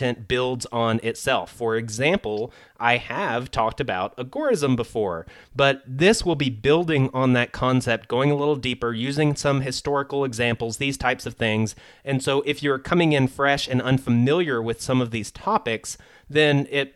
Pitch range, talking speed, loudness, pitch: 120-140 Hz, 165 wpm, -23 LUFS, 130 Hz